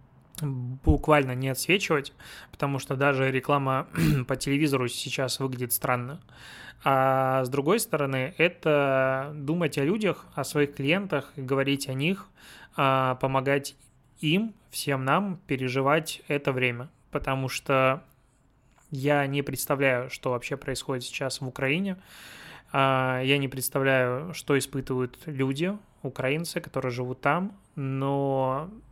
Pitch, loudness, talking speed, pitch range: 135 Hz, -27 LUFS, 115 wpm, 130-150 Hz